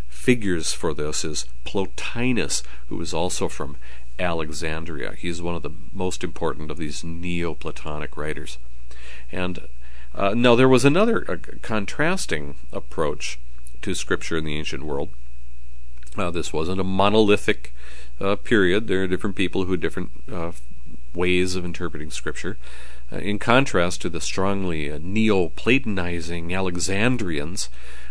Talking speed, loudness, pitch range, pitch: 135 wpm, -24 LUFS, 65-95 Hz, 80 Hz